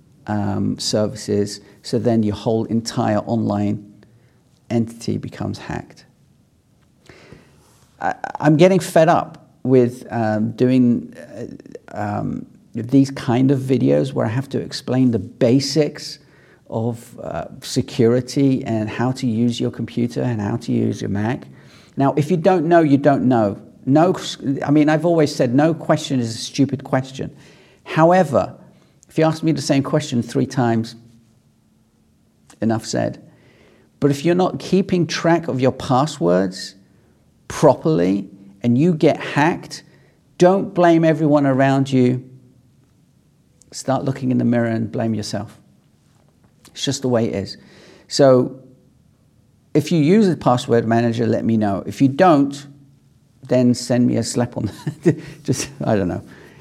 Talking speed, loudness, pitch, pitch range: 145 wpm, -18 LUFS, 130 Hz, 115-145 Hz